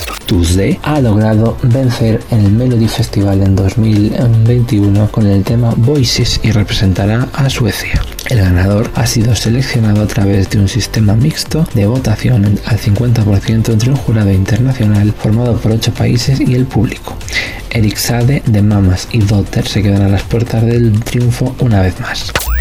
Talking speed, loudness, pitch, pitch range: 155 wpm, -12 LUFS, 110 Hz, 100-120 Hz